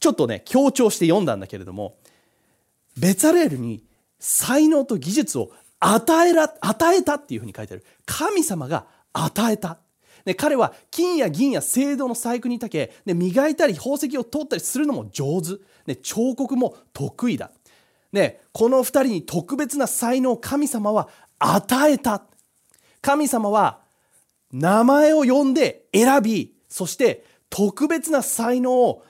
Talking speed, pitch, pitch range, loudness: 270 characters per minute, 250 Hz, 205-290 Hz, -20 LUFS